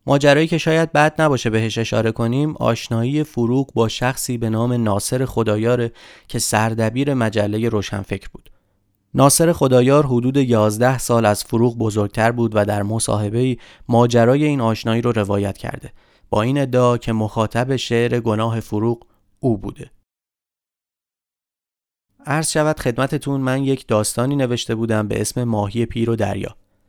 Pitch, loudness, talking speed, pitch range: 115 Hz, -18 LUFS, 140 wpm, 110-130 Hz